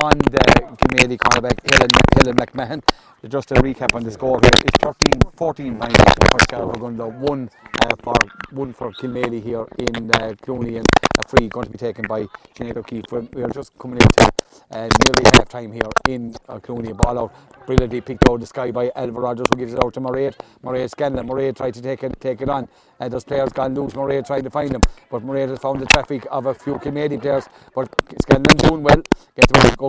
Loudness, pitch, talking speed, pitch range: -17 LUFS, 125 Hz, 215 wpm, 120-135 Hz